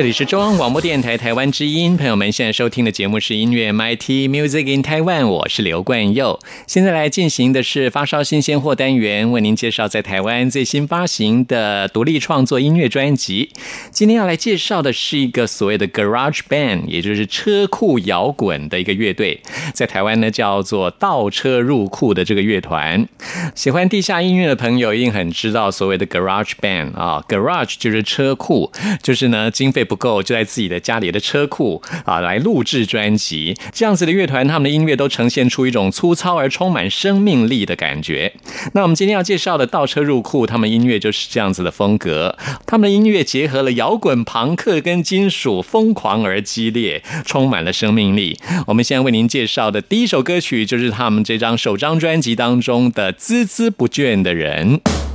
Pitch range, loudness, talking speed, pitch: 110-165 Hz, -16 LUFS, 330 characters per minute, 130 Hz